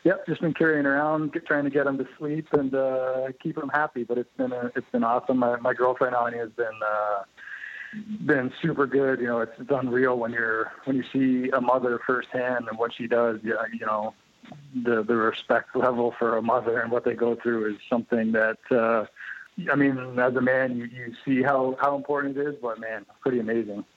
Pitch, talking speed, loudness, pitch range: 125 Hz, 215 wpm, -25 LUFS, 115-140 Hz